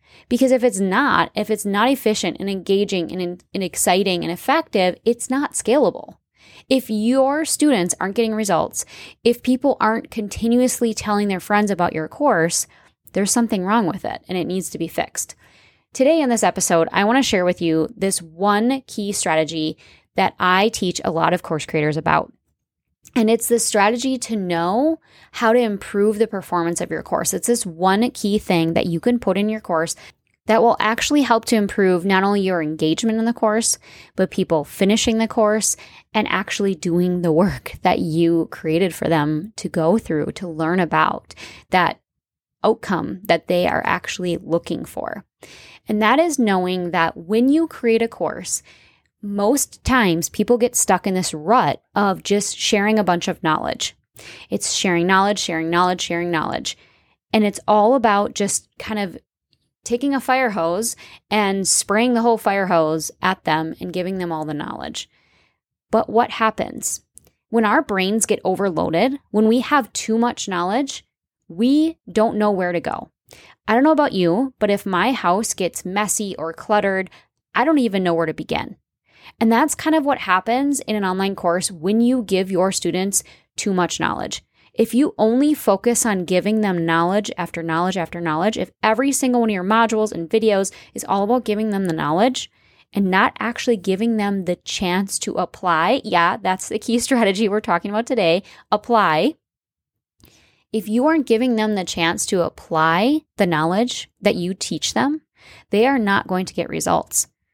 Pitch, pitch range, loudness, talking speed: 205 Hz, 180-230 Hz, -19 LUFS, 180 wpm